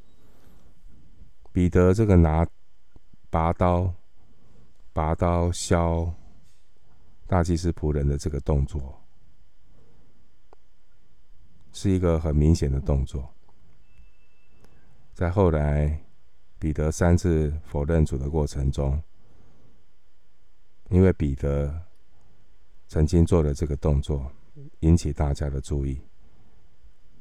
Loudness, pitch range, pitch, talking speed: -24 LUFS, 75-90 Hz, 80 Hz, 135 characters per minute